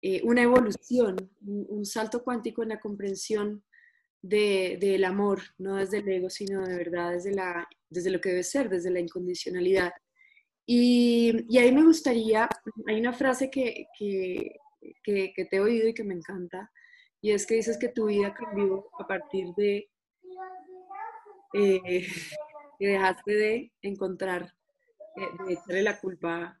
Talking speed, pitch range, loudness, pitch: 160 wpm, 190-245 Hz, -27 LUFS, 205 Hz